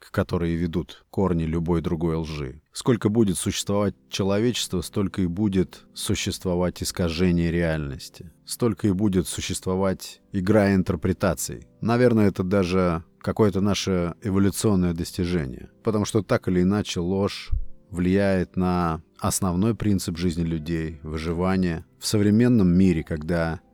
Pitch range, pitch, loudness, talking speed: 85-100 Hz, 95 Hz, -24 LUFS, 115 wpm